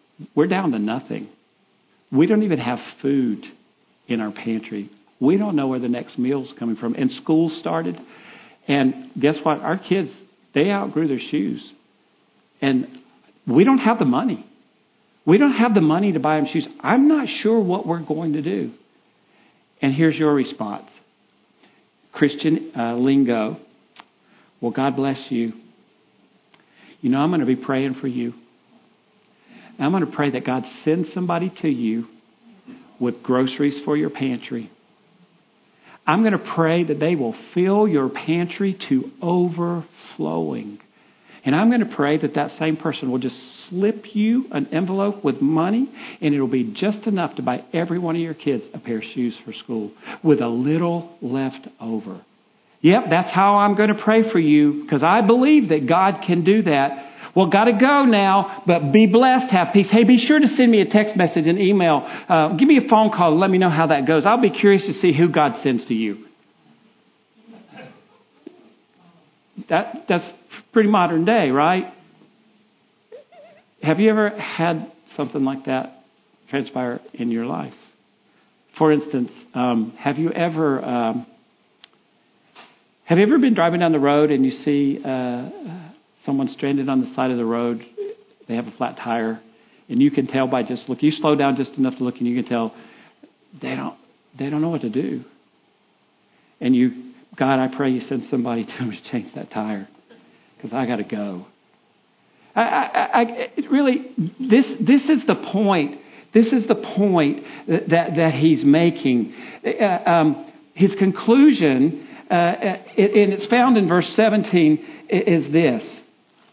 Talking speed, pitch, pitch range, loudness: 170 wpm, 165 Hz, 135-210 Hz, -19 LUFS